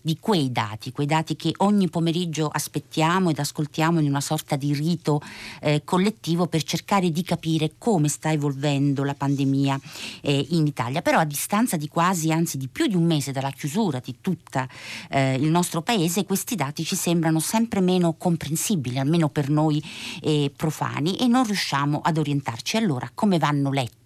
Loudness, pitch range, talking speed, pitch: -23 LUFS, 145-175 Hz, 175 wpm, 155 Hz